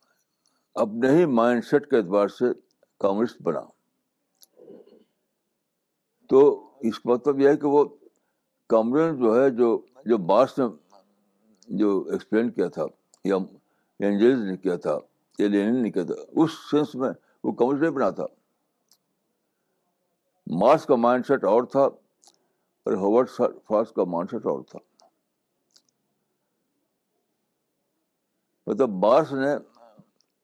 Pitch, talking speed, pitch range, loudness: 125 Hz, 120 wpm, 105-145 Hz, -23 LUFS